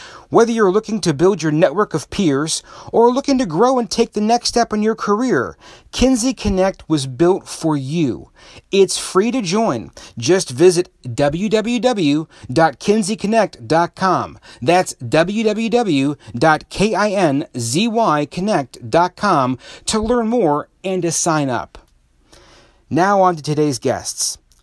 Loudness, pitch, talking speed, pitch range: -17 LUFS, 180 Hz, 115 wpm, 150-220 Hz